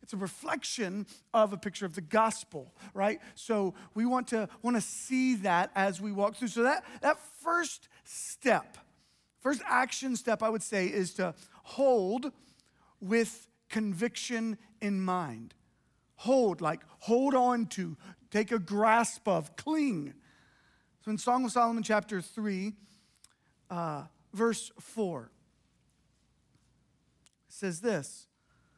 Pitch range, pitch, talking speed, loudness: 195-240 Hz, 215 Hz, 130 wpm, -31 LUFS